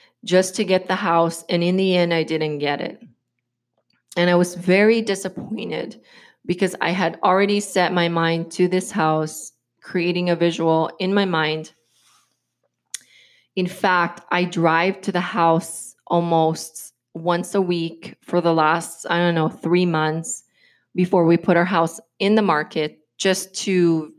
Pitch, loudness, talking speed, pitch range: 175 Hz, -20 LUFS, 155 wpm, 165-185 Hz